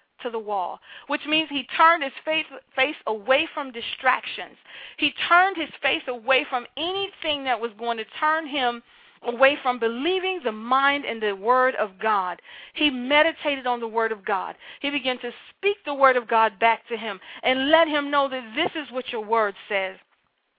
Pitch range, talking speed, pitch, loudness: 230-305 Hz, 190 wpm, 265 Hz, -23 LUFS